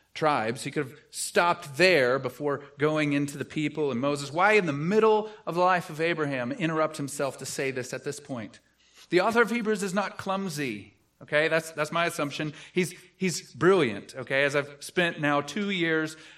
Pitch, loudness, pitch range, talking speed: 155 Hz, -27 LUFS, 145-180 Hz, 190 wpm